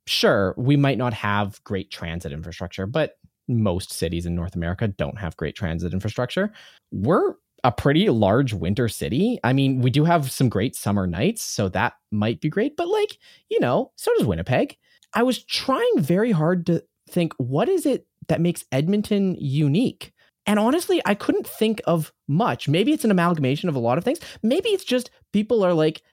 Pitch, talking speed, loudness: 155 Hz, 190 wpm, -22 LUFS